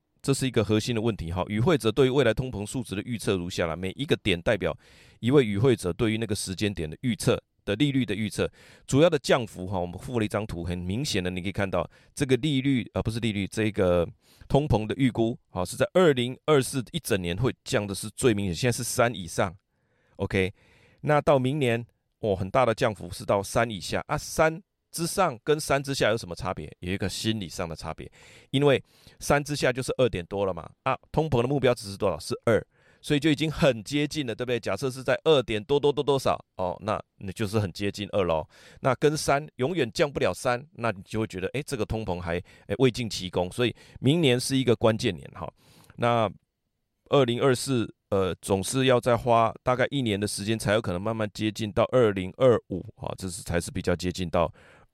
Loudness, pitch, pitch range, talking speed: -26 LUFS, 115 Hz, 100-130 Hz, 320 characters per minute